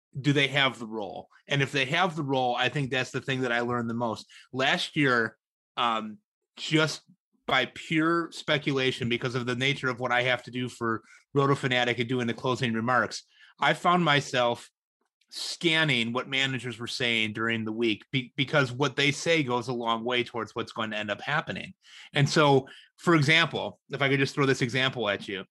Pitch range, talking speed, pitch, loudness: 120-145 Hz, 200 wpm, 130 Hz, -27 LUFS